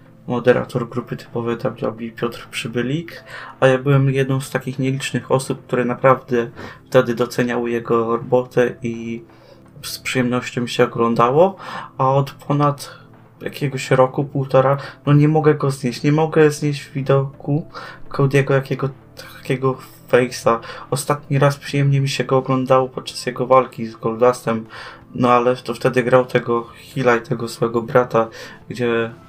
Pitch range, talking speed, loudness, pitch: 120-135 Hz, 145 wpm, -19 LUFS, 130 Hz